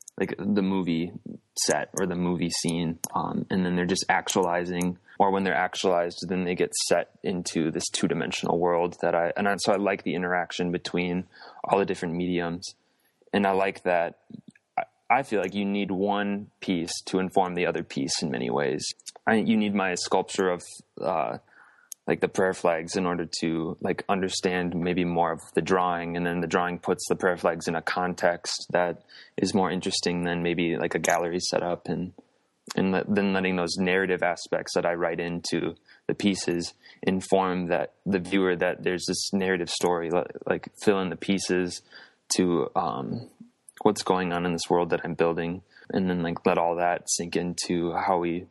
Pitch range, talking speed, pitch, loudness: 85-95 Hz, 185 wpm, 90 Hz, -27 LUFS